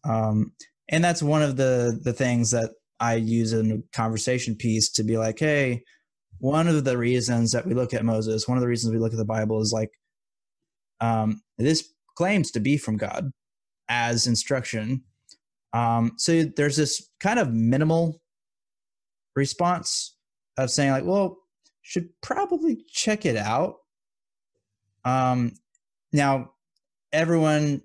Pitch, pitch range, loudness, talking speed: 125 Hz, 115-155 Hz, -24 LUFS, 145 wpm